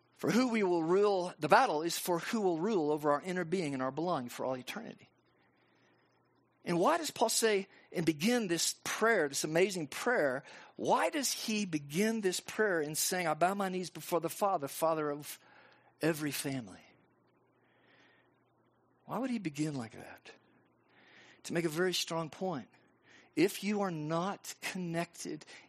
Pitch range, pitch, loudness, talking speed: 155-200 Hz, 175 Hz, -33 LUFS, 165 wpm